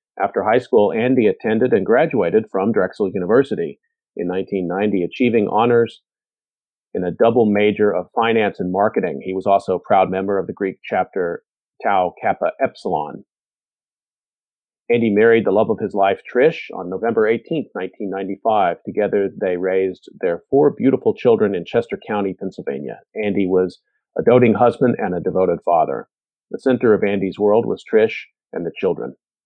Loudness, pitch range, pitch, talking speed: -18 LUFS, 95-120 Hz, 105 Hz, 155 wpm